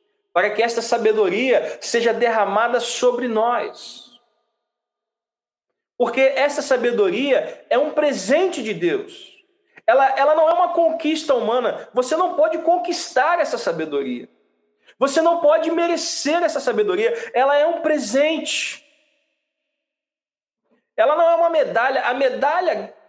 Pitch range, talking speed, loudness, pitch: 255-335 Hz, 120 wpm, -19 LUFS, 305 Hz